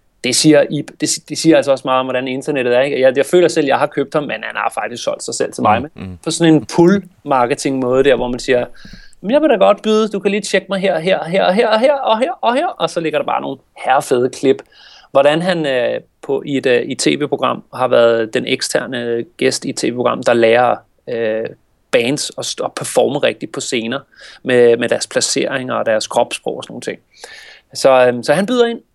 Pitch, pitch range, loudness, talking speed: 150 Hz, 125-195 Hz, -15 LUFS, 225 wpm